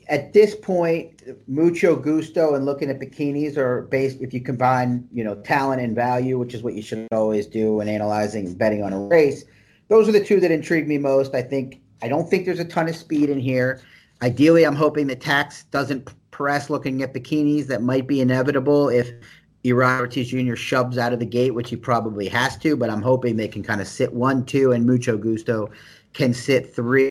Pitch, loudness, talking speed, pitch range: 130 Hz, -21 LUFS, 215 wpm, 120-145 Hz